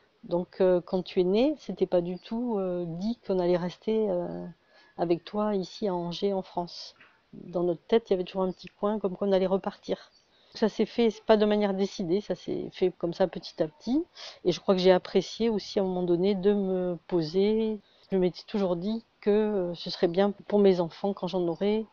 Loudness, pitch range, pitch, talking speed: -28 LUFS, 180-210 Hz, 190 Hz, 225 wpm